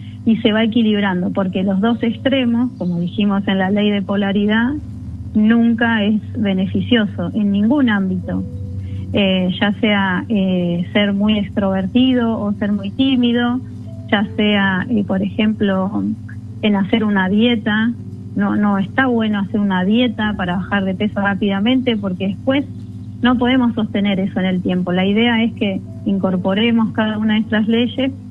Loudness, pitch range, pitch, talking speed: -17 LUFS, 190-230 Hz, 205 Hz, 155 wpm